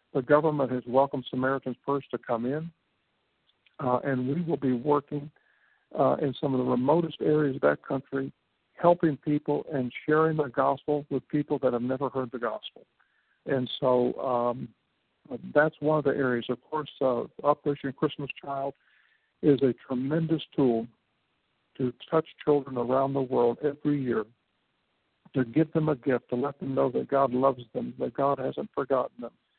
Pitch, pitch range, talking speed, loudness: 135 Hz, 125-150 Hz, 170 wpm, -28 LUFS